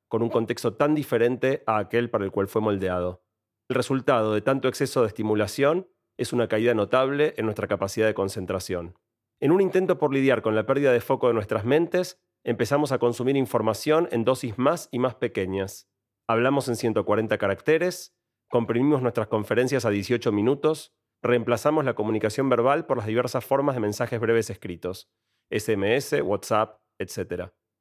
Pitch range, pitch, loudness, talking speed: 110-135 Hz, 120 Hz, -25 LUFS, 165 wpm